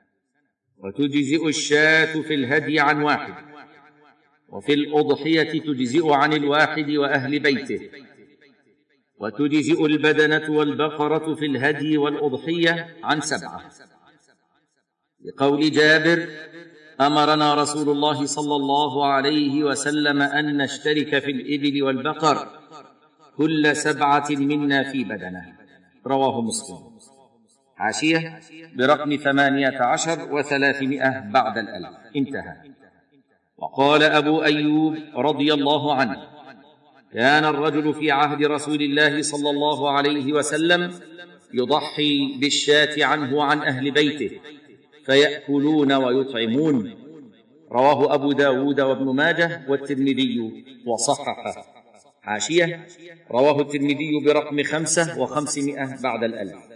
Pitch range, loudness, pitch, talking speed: 140-150 Hz, -20 LUFS, 150 Hz, 95 wpm